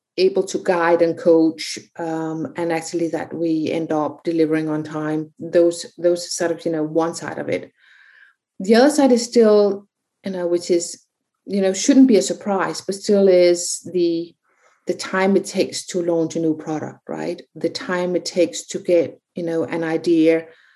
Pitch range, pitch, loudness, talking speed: 165-190 Hz, 170 Hz, -19 LUFS, 185 wpm